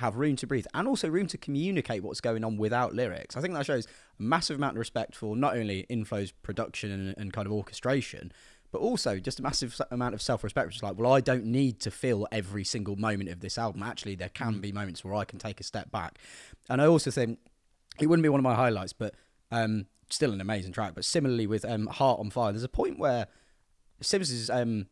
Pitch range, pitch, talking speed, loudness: 105-130 Hz, 115 Hz, 240 wpm, -30 LUFS